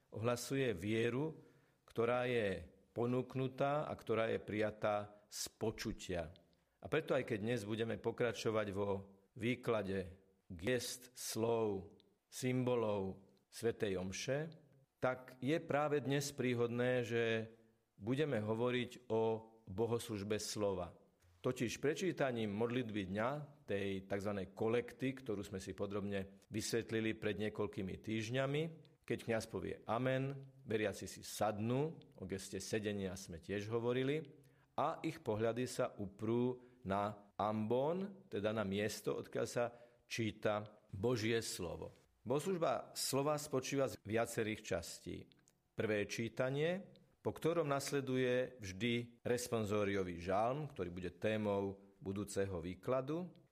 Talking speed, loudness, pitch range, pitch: 110 wpm, -40 LUFS, 100-130 Hz, 115 Hz